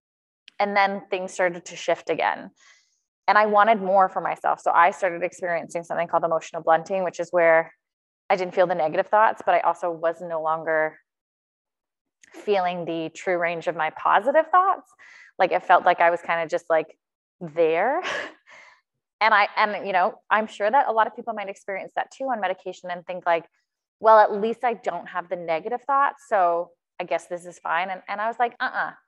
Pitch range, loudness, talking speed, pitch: 170-205 Hz, -23 LUFS, 200 wpm, 180 Hz